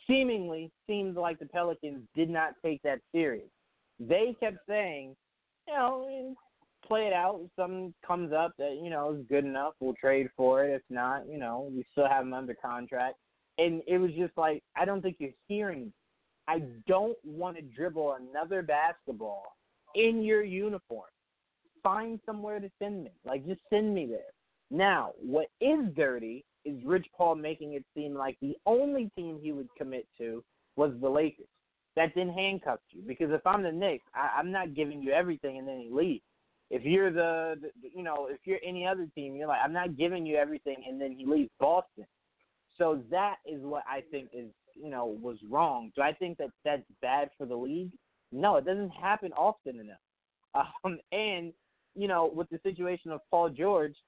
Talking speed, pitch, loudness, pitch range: 190 wpm, 160 Hz, -32 LUFS, 140-190 Hz